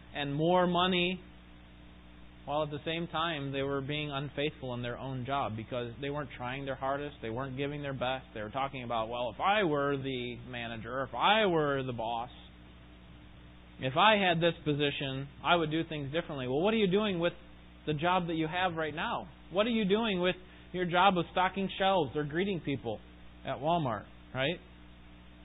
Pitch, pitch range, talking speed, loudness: 140 Hz, 115-170 Hz, 190 wpm, -32 LUFS